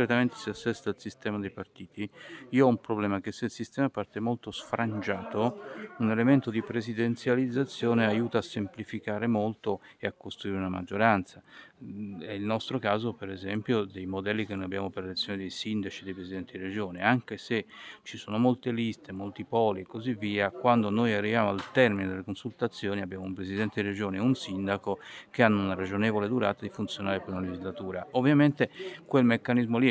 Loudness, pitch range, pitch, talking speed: -30 LUFS, 100-115 Hz, 105 Hz, 185 wpm